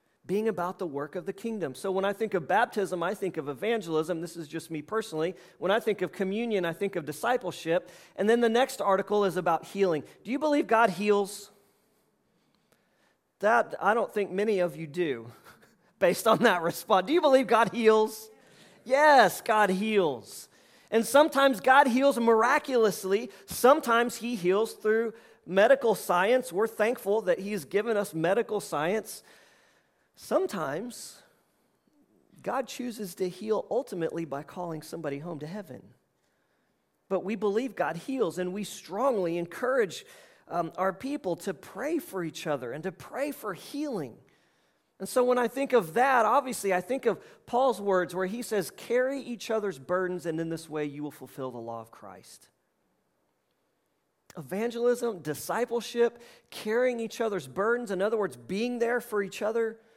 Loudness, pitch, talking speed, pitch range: -28 LUFS, 205 Hz, 160 wpm, 180-235 Hz